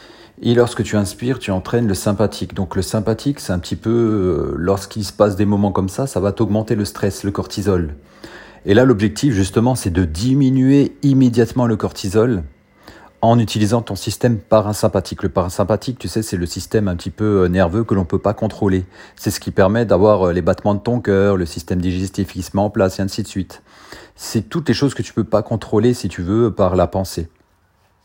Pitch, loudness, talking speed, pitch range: 105 Hz, -18 LUFS, 210 wpm, 95-115 Hz